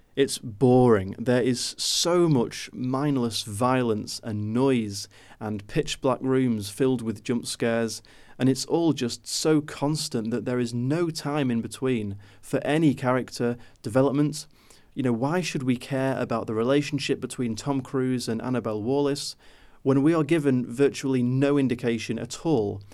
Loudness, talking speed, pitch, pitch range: -25 LUFS, 155 wpm, 125 Hz, 115-140 Hz